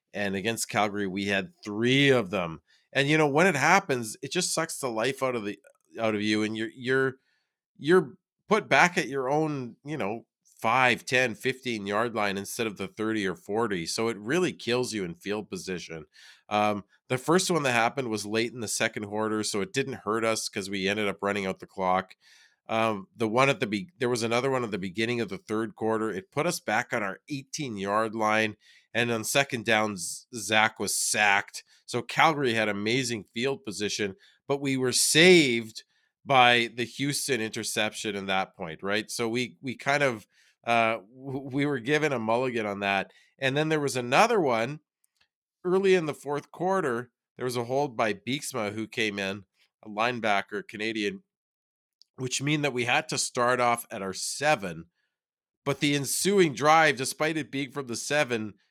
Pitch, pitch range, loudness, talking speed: 120 Hz, 105-140 Hz, -27 LUFS, 190 wpm